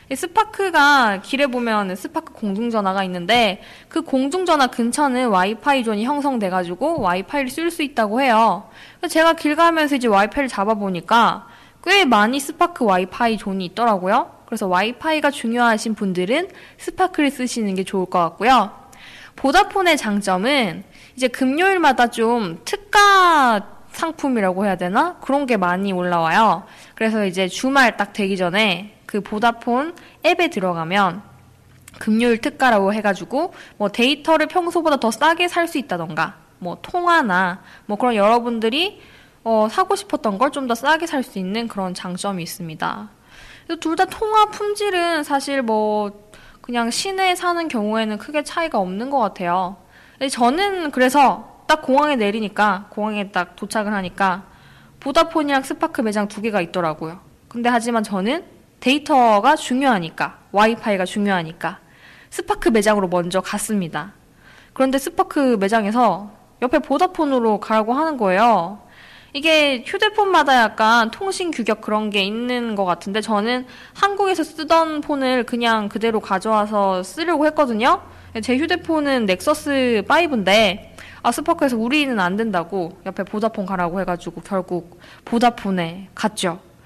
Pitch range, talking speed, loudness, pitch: 200-295 Hz, 325 characters per minute, -19 LUFS, 230 Hz